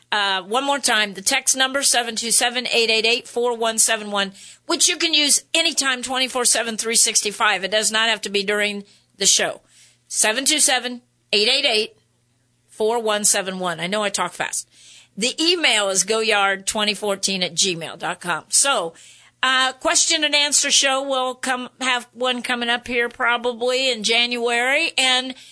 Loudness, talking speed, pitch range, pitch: -18 LUFS, 145 wpm, 210-260 Hz, 235 Hz